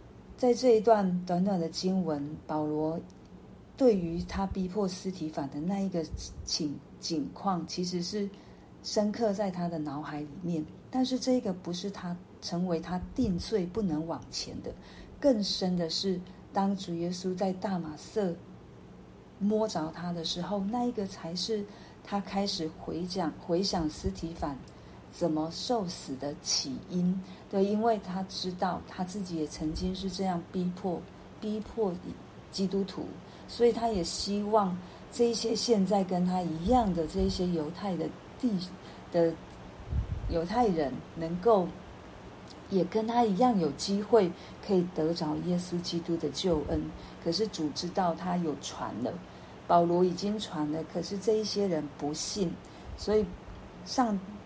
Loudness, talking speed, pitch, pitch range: -31 LUFS, 210 characters per minute, 185 Hz, 165-205 Hz